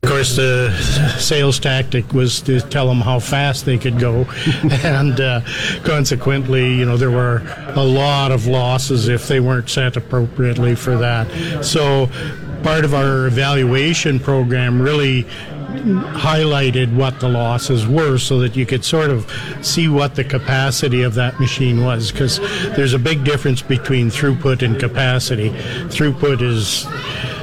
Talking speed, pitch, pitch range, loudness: 150 wpm, 130 Hz, 125-140 Hz, -16 LUFS